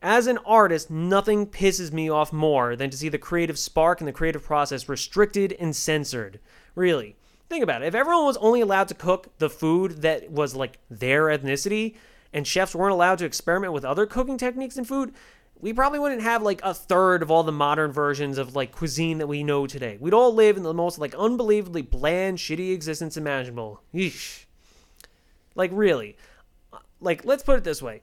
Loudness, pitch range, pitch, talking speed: -24 LUFS, 150-205 Hz, 170 Hz, 195 wpm